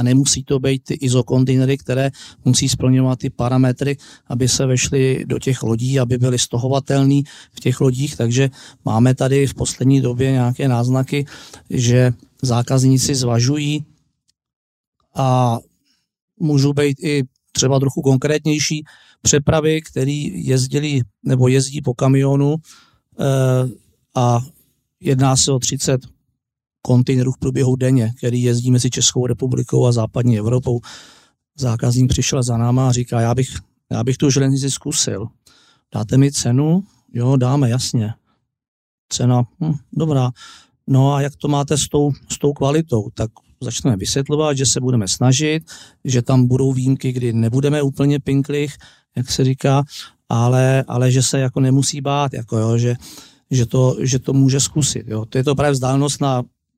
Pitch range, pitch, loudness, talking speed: 125-140 Hz, 130 Hz, -17 LUFS, 145 wpm